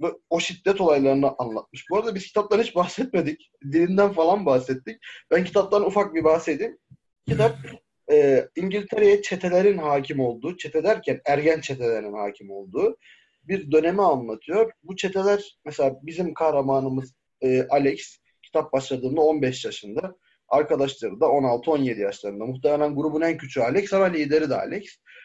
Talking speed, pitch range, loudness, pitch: 135 wpm, 135-195 Hz, -23 LUFS, 160 Hz